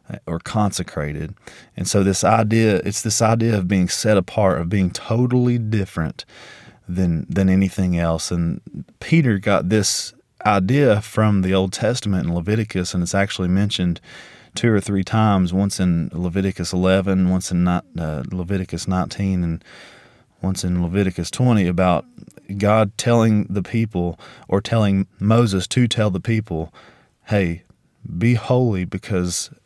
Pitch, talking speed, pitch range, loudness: 100 Hz, 140 wpm, 90-110 Hz, -20 LUFS